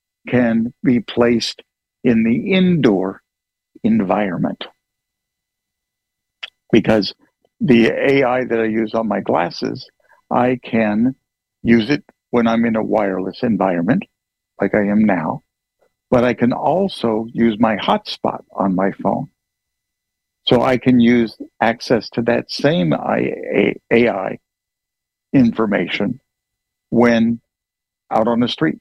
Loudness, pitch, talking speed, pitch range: -17 LUFS, 120 Hz, 115 wpm, 110-125 Hz